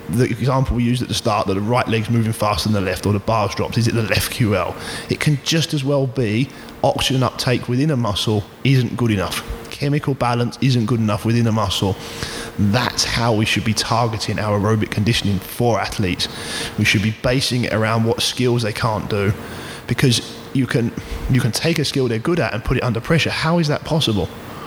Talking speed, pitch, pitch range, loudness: 215 wpm, 115 Hz, 110-125 Hz, -19 LUFS